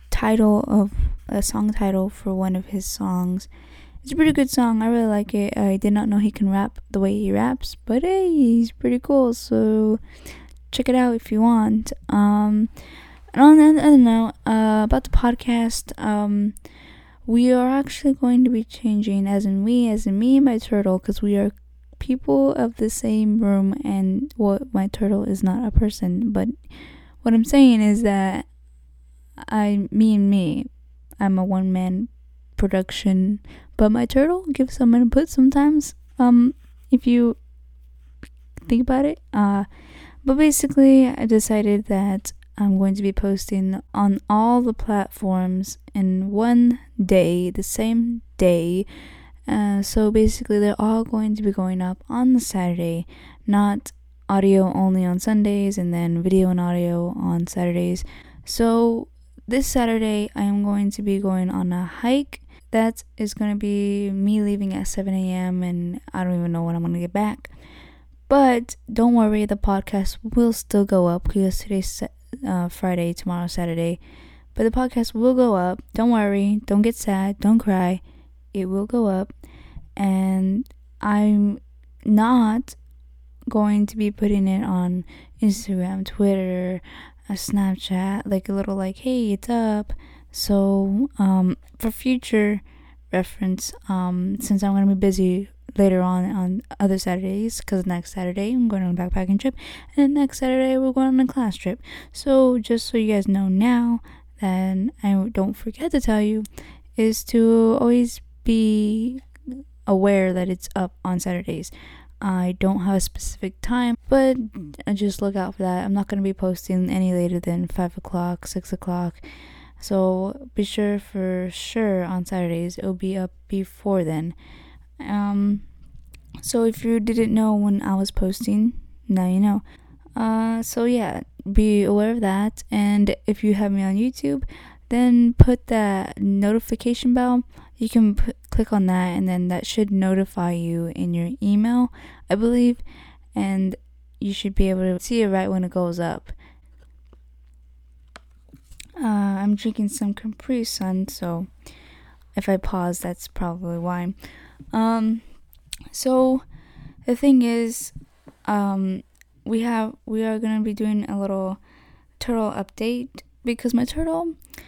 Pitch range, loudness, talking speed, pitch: 185-230 Hz, -21 LUFS, 160 wpm, 205 Hz